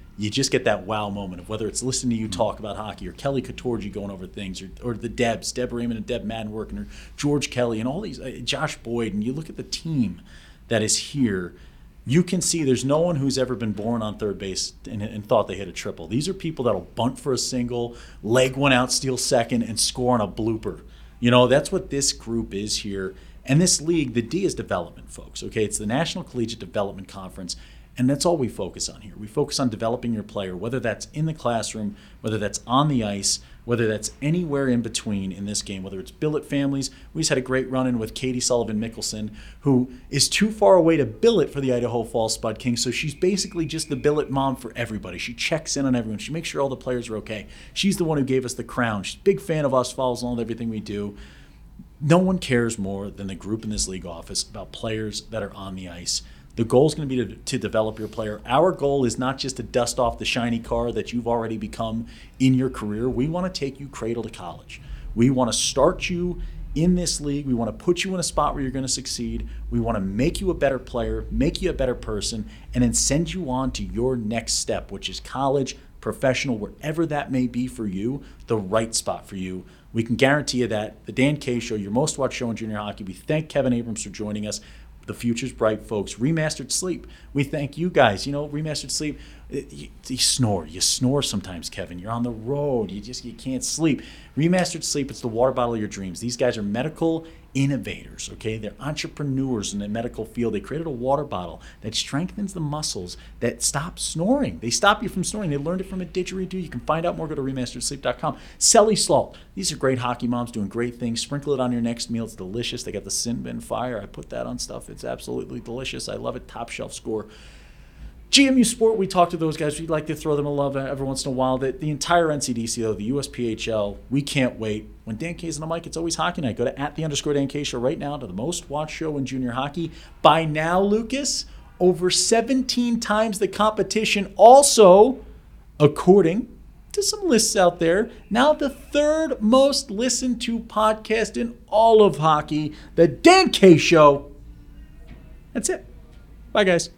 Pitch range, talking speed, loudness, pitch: 110-155 Hz, 225 wpm, -23 LUFS, 125 Hz